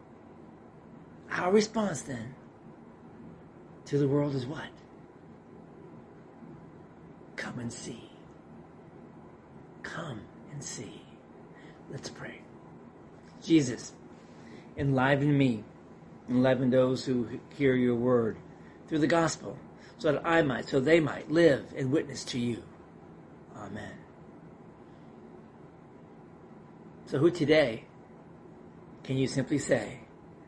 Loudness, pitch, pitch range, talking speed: -29 LUFS, 135 Hz, 120-155 Hz, 95 wpm